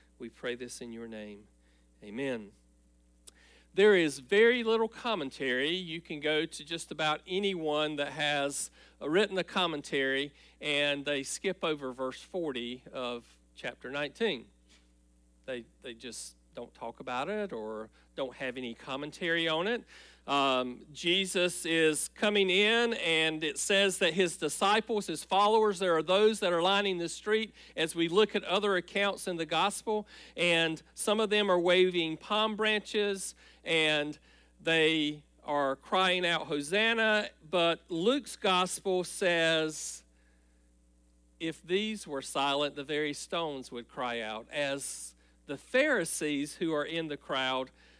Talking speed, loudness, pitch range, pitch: 140 wpm, -30 LUFS, 130-190 Hz, 160 Hz